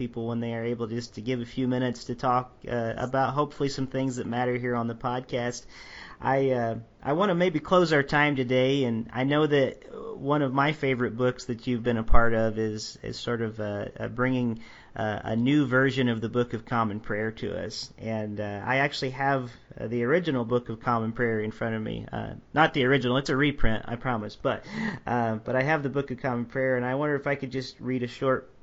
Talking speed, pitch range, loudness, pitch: 235 wpm, 115-135 Hz, -27 LUFS, 125 Hz